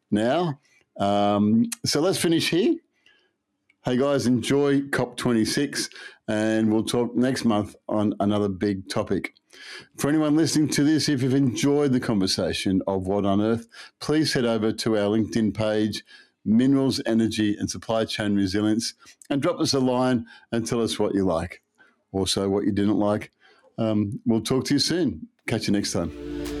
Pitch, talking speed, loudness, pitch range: 115 Hz, 160 wpm, -24 LUFS, 105-140 Hz